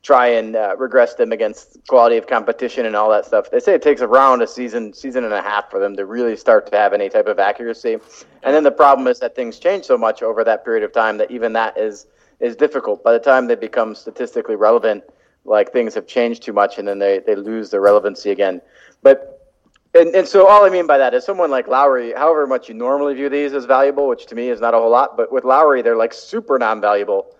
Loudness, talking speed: -15 LUFS, 245 wpm